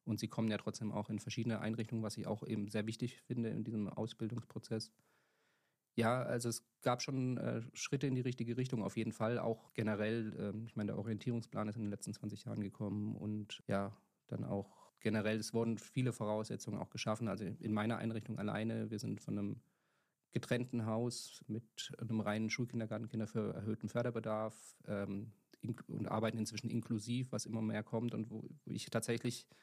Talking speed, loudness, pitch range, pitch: 185 wpm, -41 LUFS, 105-115 Hz, 110 Hz